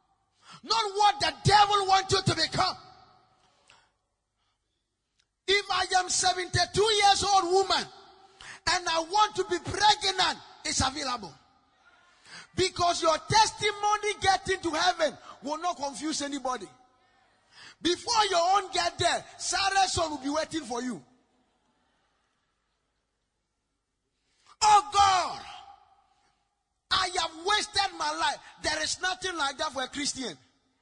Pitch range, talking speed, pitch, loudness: 320-400 Hz, 115 wpm, 370 Hz, -26 LUFS